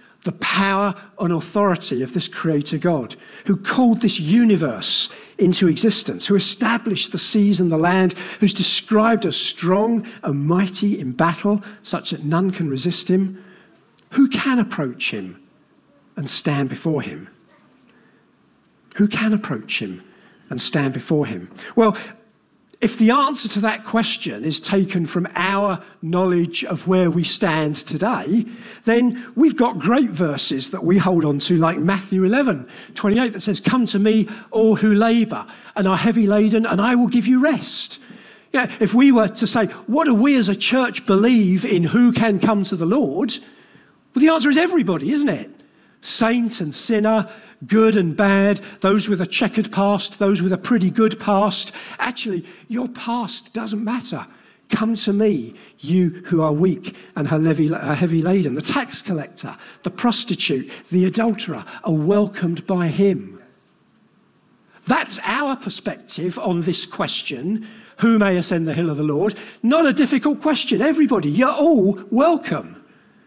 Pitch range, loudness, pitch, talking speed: 180-230 Hz, -19 LUFS, 205 Hz, 155 wpm